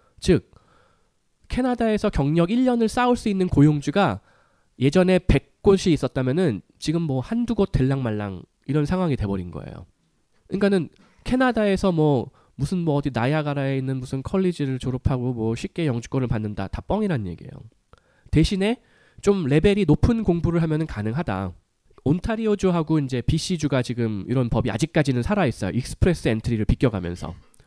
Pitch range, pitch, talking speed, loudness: 125-185 Hz, 145 Hz, 355 characters per minute, -23 LUFS